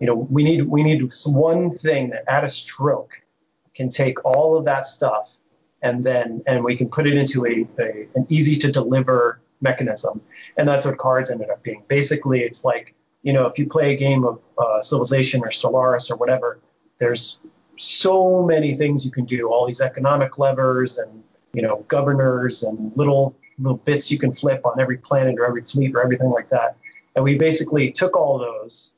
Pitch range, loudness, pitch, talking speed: 125-145 Hz, -19 LUFS, 130 Hz, 200 wpm